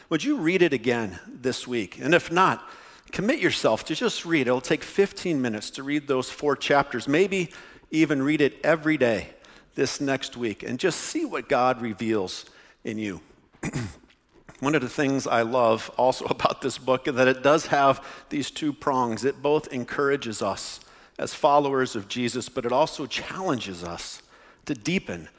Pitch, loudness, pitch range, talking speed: 140 Hz, -25 LUFS, 125-155 Hz, 175 wpm